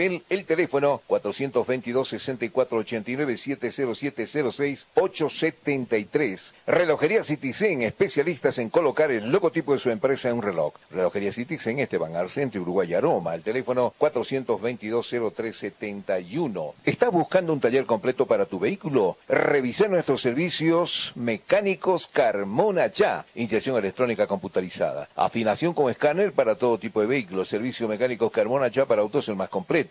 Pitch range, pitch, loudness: 115-150 Hz, 130 Hz, -25 LUFS